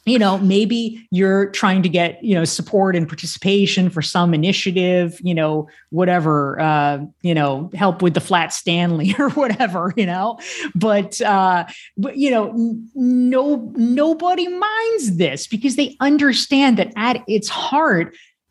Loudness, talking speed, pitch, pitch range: -18 LUFS, 150 wpm, 195 Hz, 175-235 Hz